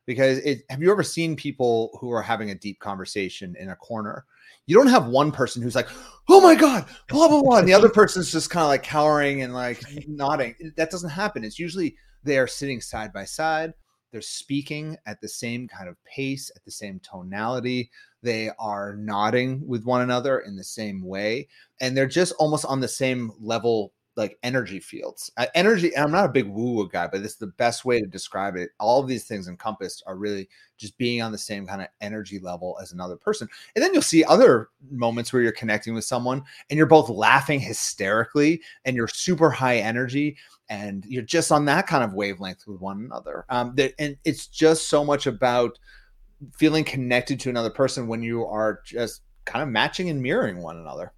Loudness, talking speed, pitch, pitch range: -22 LUFS, 210 wpm, 125 Hz, 110-150 Hz